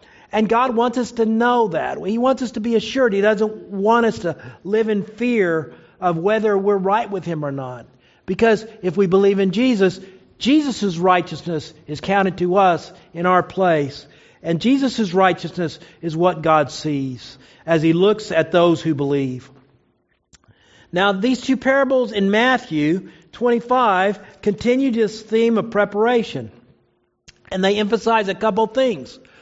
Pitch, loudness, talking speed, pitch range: 195 Hz, -19 LUFS, 155 wpm, 165-225 Hz